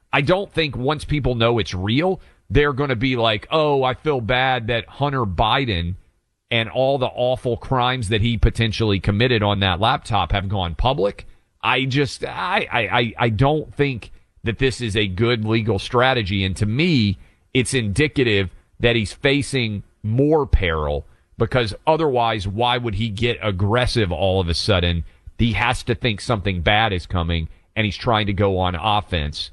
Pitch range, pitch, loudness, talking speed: 100-125 Hz, 115 Hz, -20 LUFS, 175 wpm